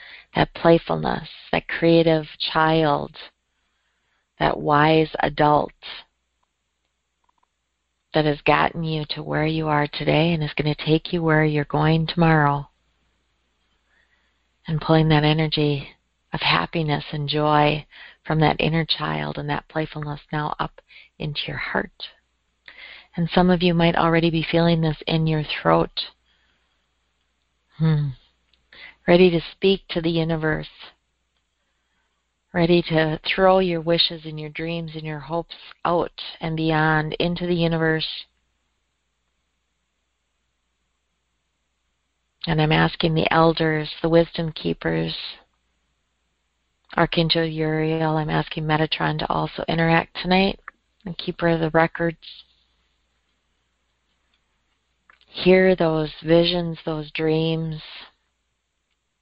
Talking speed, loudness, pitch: 110 wpm, -21 LUFS, 155 Hz